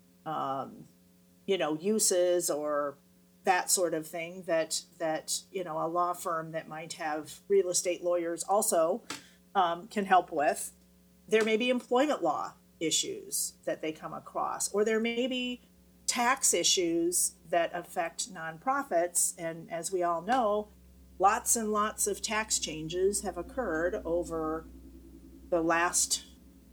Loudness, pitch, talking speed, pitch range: -30 LUFS, 175 Hz, 140 wpm, 155-210 Hz